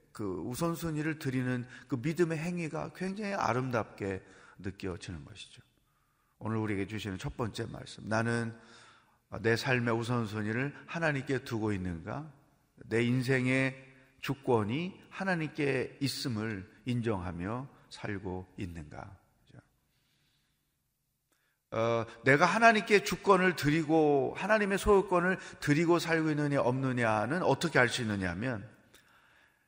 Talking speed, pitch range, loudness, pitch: 260 characters per minute, 115-160 Hz, -31 LUFS, 130 Hz